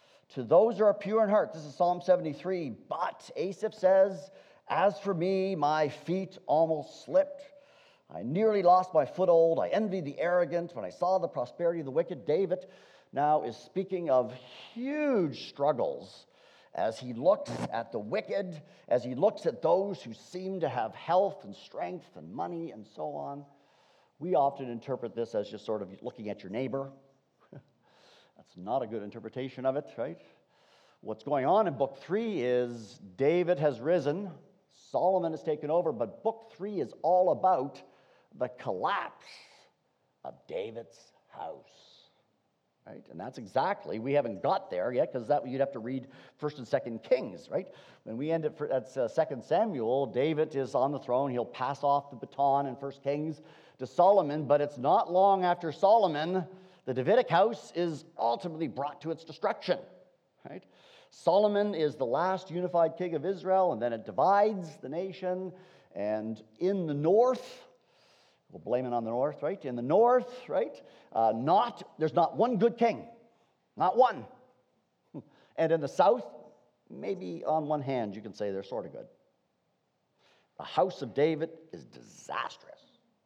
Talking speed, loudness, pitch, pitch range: 165 wpm, -30 LUFS, 165 Hz, 135-190 Hz